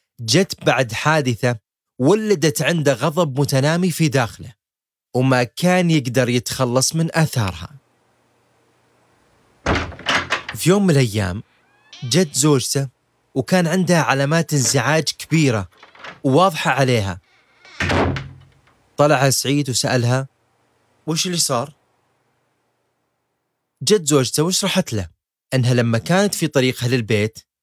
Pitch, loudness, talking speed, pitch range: 135 Hz, -18 LUFS, 95 wpm, 120-155 Hz